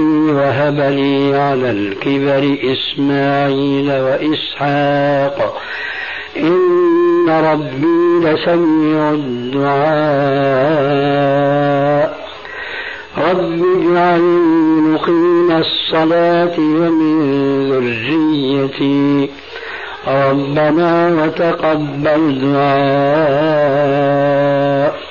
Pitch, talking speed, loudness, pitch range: 145 Hz, 45 wpm, -14 LUFS, 140-165 Hz